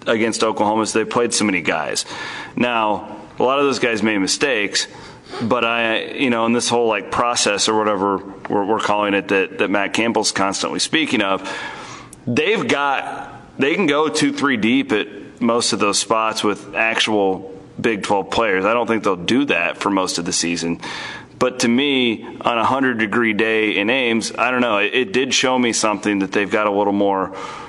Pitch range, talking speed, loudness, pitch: 105-120 Hz, 200 wpm, -18 LUFS, 110 Hz